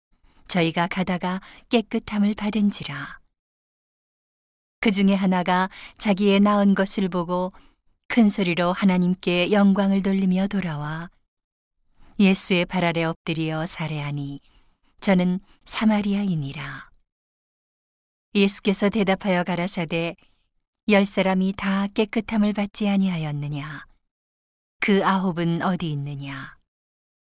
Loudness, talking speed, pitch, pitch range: -22 LUFS, 235 characters per minute, 190 Hz, 170-200 Hz